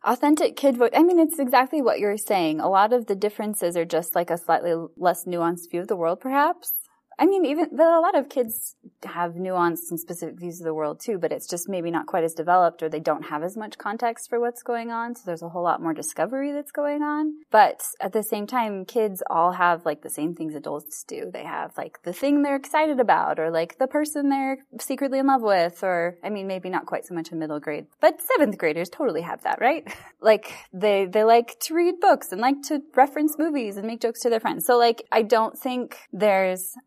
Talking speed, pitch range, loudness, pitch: 235 wpm, 175-275 Hz, -23 LUFS, 215 Hz